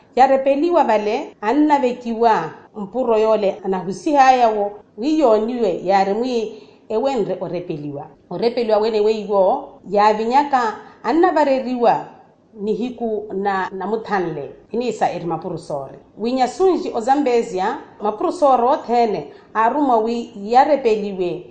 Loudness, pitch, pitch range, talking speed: -18 LUFS, 225 Hz, 200-255 Hz, 90 wpm